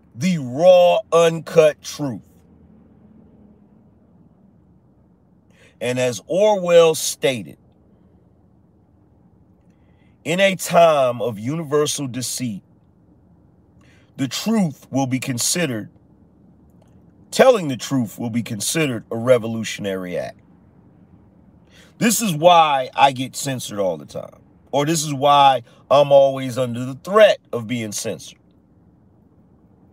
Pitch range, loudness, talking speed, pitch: 120-165 Hz, -18 LUFS, 100 wpm, 140 Hz